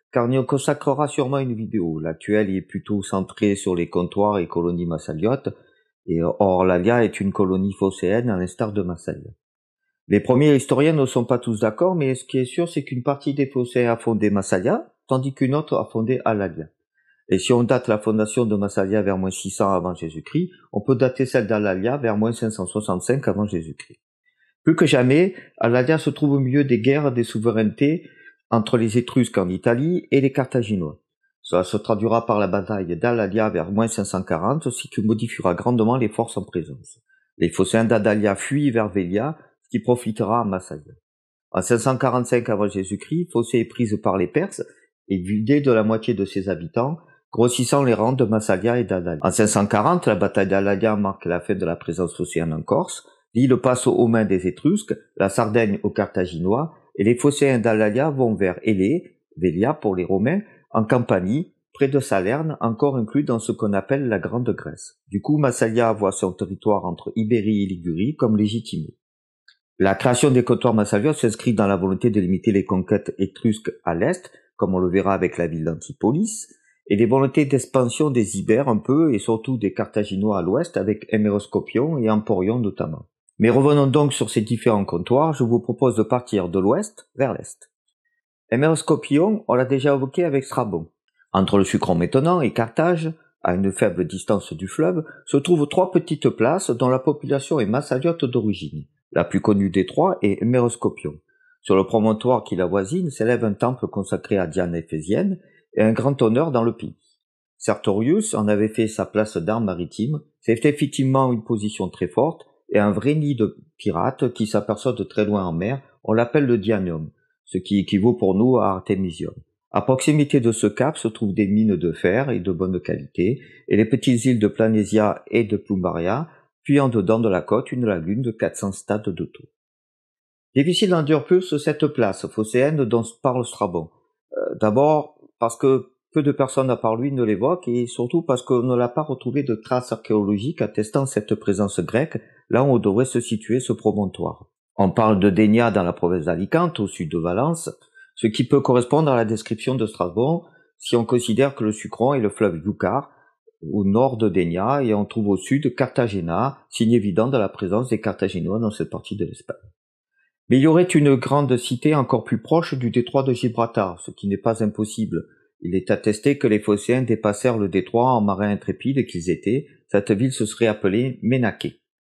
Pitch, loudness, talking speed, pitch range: 115 Hz, -21 LUFS, 190 wpm, 100-135 Hz